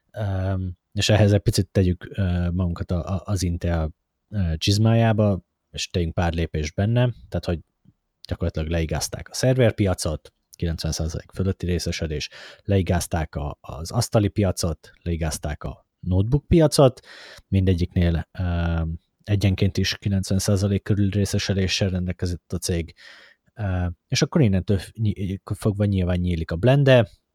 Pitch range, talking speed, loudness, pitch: 85-105 Hz, 110 wpm, -23 LUFS, 95 Hz